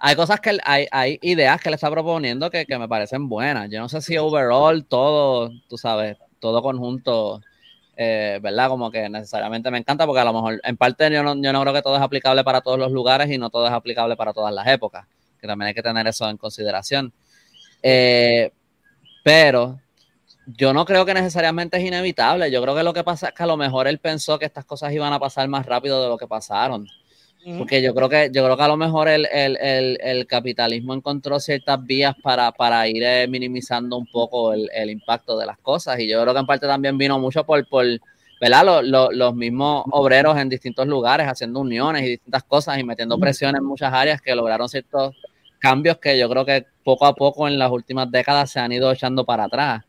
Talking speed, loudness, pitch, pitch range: 220 wpm, -19 LUFS, 130 Hz, 120-145 Hz